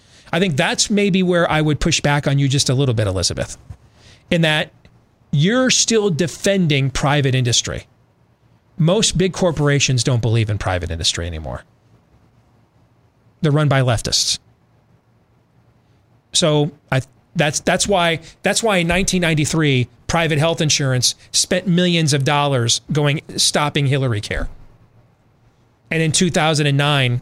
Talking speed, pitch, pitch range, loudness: 130 wpm, 140 Hz, 120-165 Hz, -17 LUFS